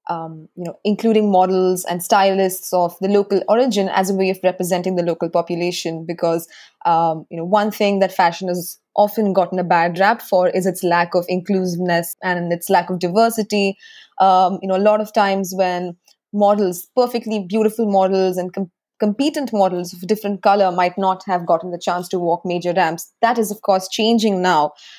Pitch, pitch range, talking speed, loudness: 185 Hz, 175-205 Hz, 190 wpm, -18 LUFS